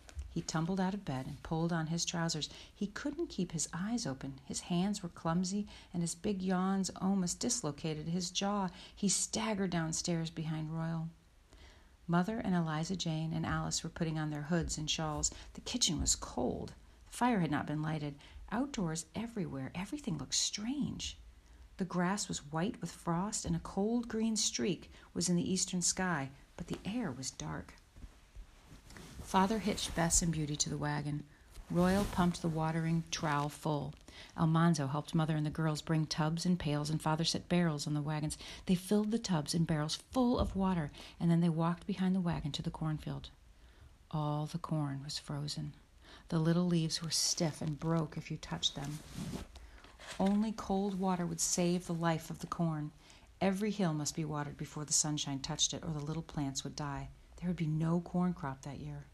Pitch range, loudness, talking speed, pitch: 150-185 Hz, -35 LUFS, 185 wpm, 165 Hz